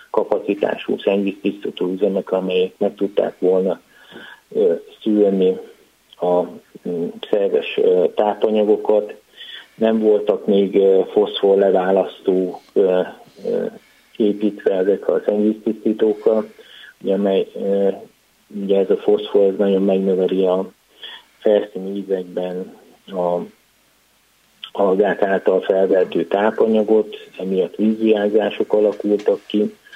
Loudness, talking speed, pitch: -18 LUFS, 75 wpm, 105 Hz